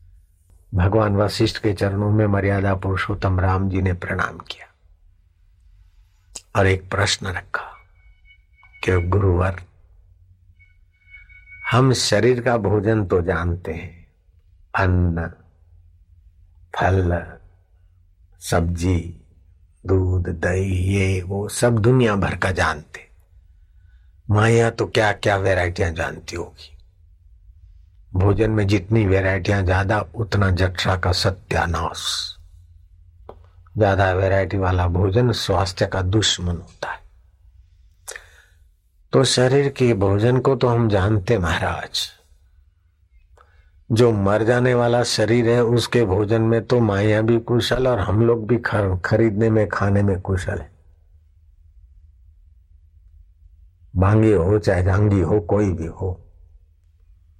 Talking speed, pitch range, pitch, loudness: 110 wpm, 85-105 Hz, 90 Hz, -20 LUFS